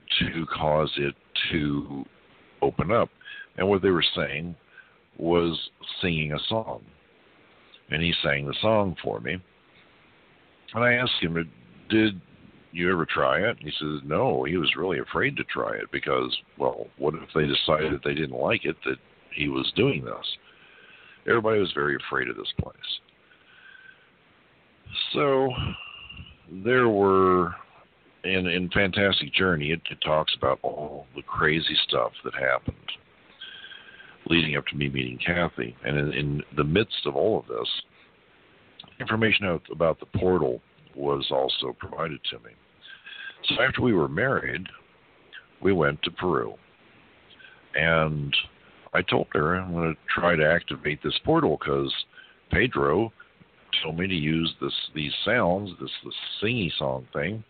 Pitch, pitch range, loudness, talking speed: 85 Hz, 75-95 Hz, -25 LUFS, 145 wpm